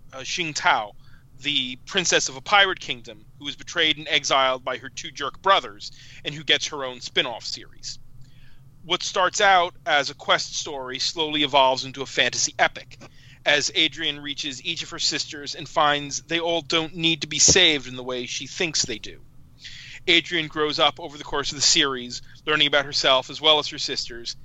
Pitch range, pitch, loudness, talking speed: 130-160 Hz, 145 Hz, -21 LUFS, 195 wpm